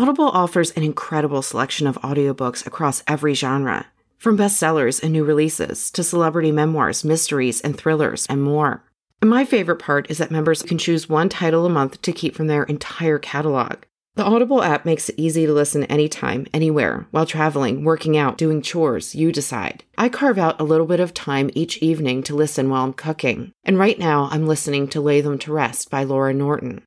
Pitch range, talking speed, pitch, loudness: 145-165 Hz, 195 wpm, 155 Hz, -19 LUFS